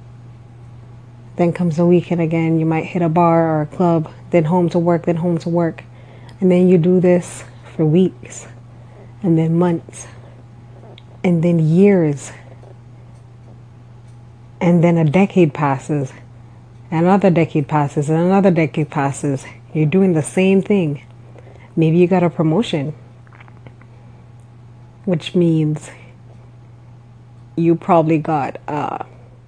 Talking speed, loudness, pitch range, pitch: 130 wpm, -16 LUFS, 120-170 Hz, 150 Hz